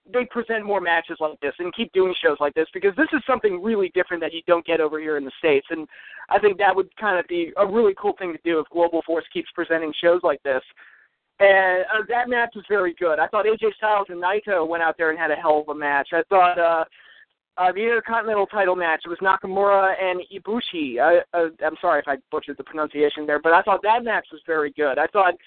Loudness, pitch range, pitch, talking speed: -21 LUFS, 160-205 Hz, 180 Hz, 245 wpm